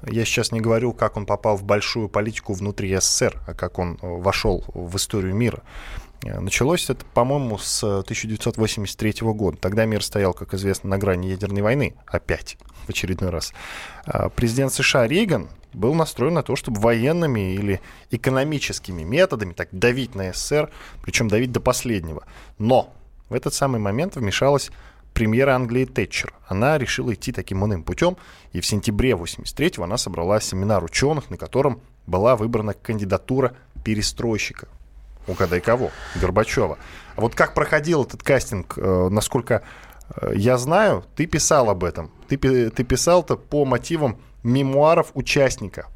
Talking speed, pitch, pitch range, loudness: 145 wpm, 110 Hz, 95-130 Hz, -22 LUFS